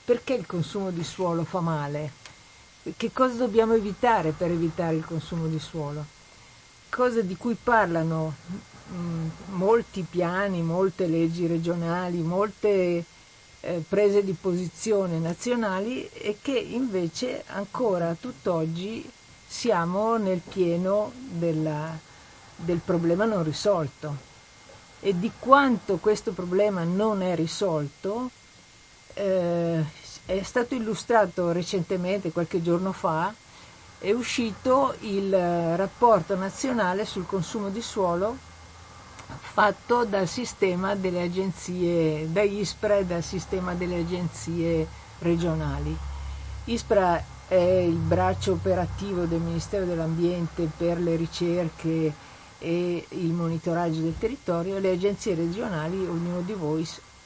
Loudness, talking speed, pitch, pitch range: -26 LUFS, 110 wpm, 180 Hz, 165-205 Hz